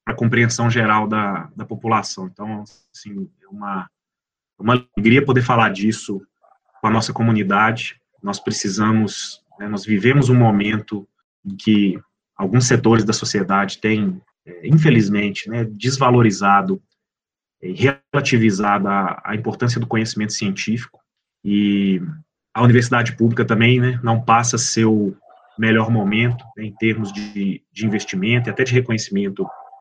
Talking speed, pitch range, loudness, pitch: 130 wpm, 105-120 Hz, -18 LUFS, 110 Hz